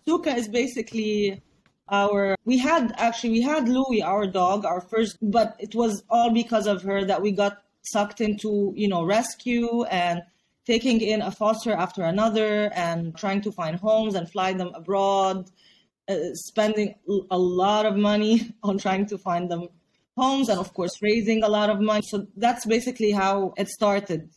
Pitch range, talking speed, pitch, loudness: 195-225 Hz, 175 wpm, 210 Hz, -24 LUFS